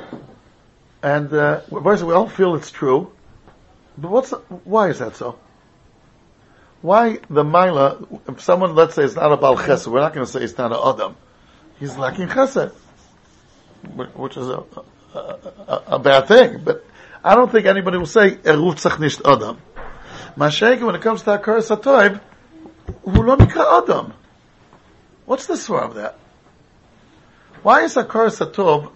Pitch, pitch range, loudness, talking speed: 195 Hz, 165-225 Hz, -16 LUFS, 145 wpm